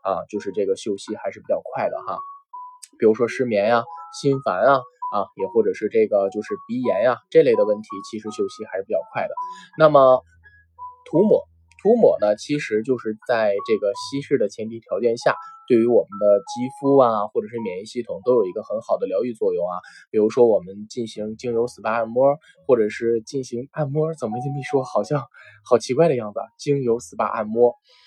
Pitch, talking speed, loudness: 140 Hz, 300 characters per minute, -21 LUFS